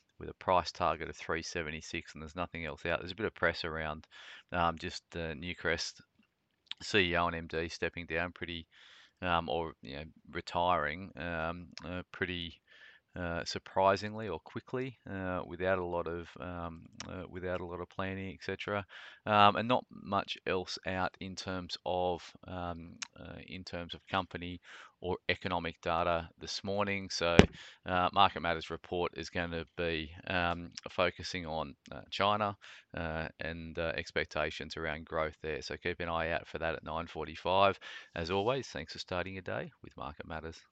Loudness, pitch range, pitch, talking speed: -35 LUFS, 80-95 Hz, 85 Hz, 165 wpm